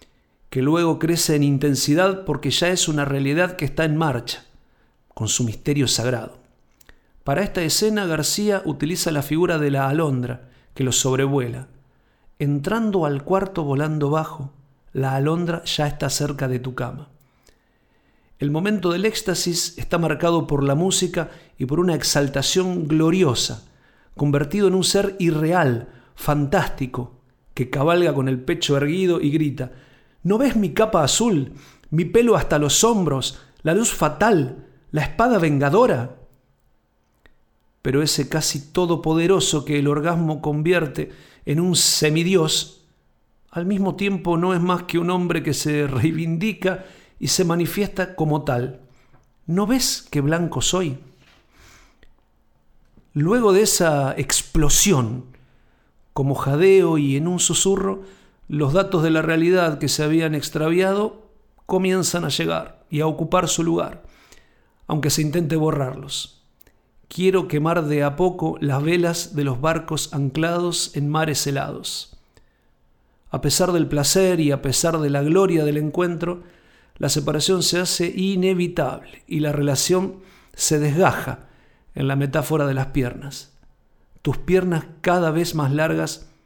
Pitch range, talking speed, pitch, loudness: 140-175 Hz, 140 wpm, 155 Hz, -20 LUFS